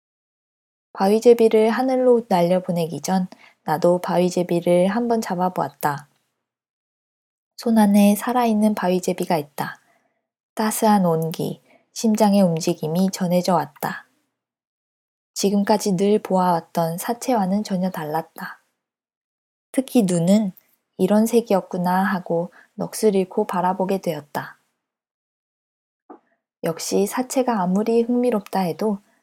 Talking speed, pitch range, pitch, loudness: 235 characters per minute, 175-220 Hz, 190 Hz, -20 LUFS